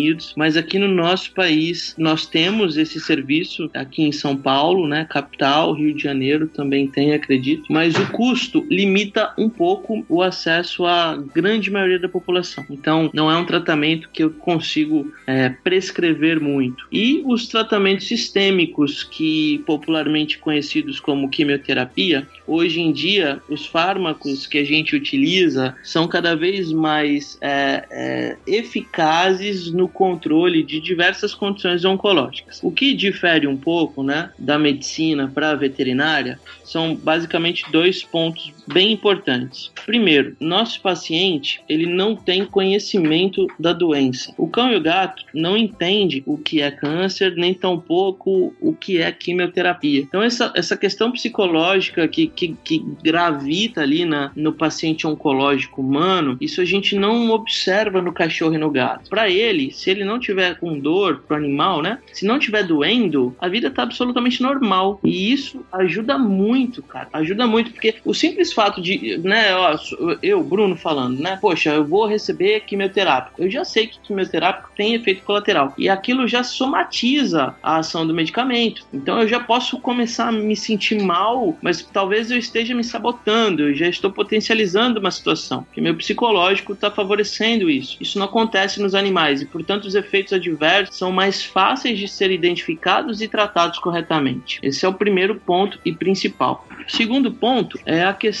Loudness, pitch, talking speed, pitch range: -18 LUFS, 190 Hz, 160 wpm, 160-225 Hz